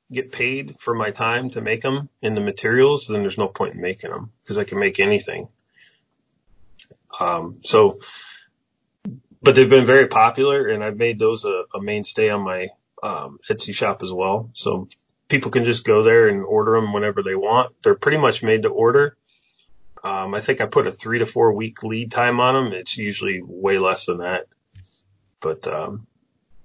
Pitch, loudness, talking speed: 135 Hz, -19 LUFS, 190 wpm